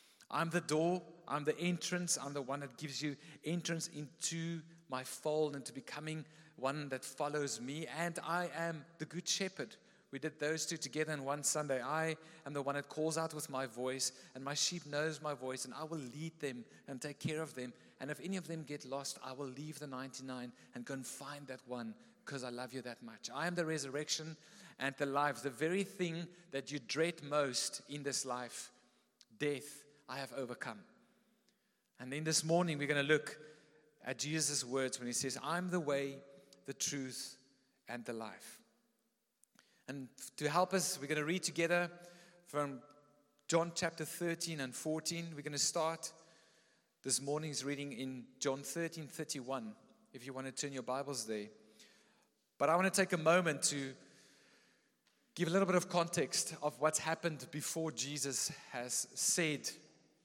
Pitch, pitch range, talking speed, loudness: 150 Hz, 135-165 Hz, 185 wpm, -39 LUFS